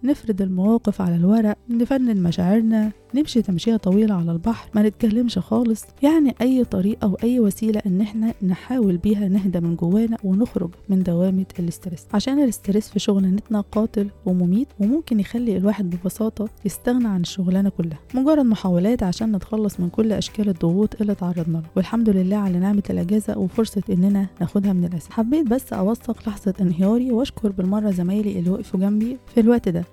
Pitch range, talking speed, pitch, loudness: 190-225 Hz, 160 wpm, 210 Hz, -21 LUFS